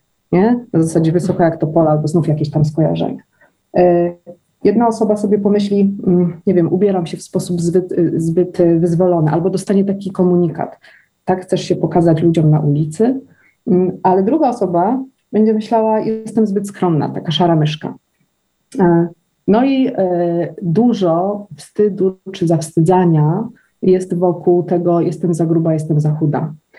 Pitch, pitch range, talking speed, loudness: 180 Hz, 170-200 Hz, 140 wpm, -15 LUFS